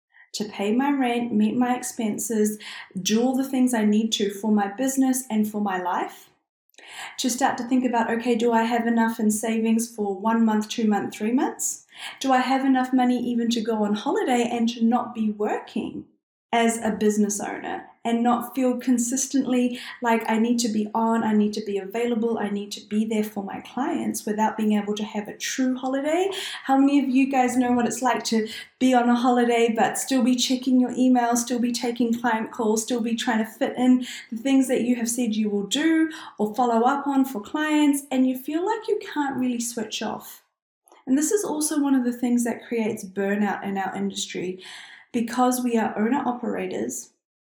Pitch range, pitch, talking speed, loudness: 220-255 Hz, 235 Hz, 205 wpm, -23 LUFS